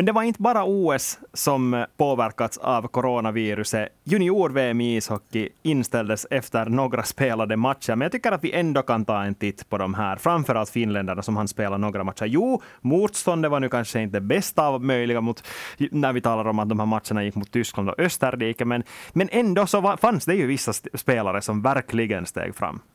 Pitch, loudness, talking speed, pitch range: 120 Hz, -23 LUFS, 200 wpm, 110-145 Hz